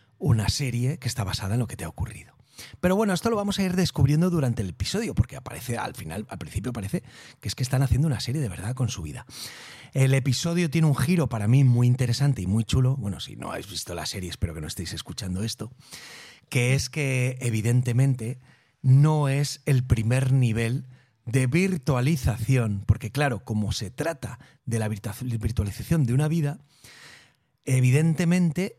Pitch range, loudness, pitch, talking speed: 110-140 Hz, -25 LUFS, 125 Hz, 185 wpm